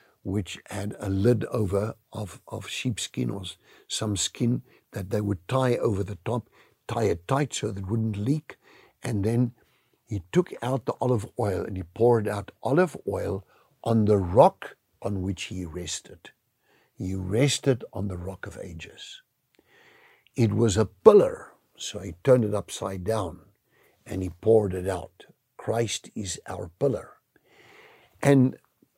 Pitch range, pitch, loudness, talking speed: 100-125 Hz, 110 Hz, -26 LUFS, 155 wpm